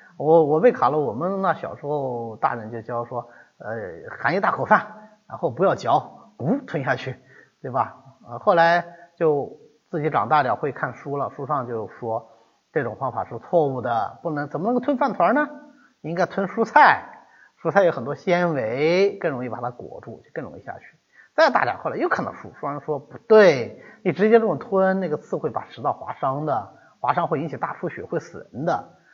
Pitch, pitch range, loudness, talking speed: 170 Hz, 140-215 Hz, -22 LUFS, 280 characters per minute